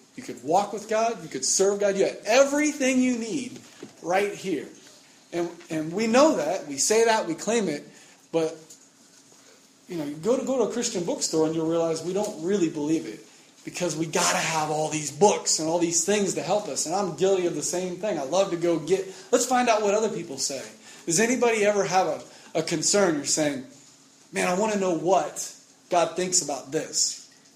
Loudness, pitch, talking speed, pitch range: -24 LUFS, 185 Hz, 215 wpm, 165-215 Hz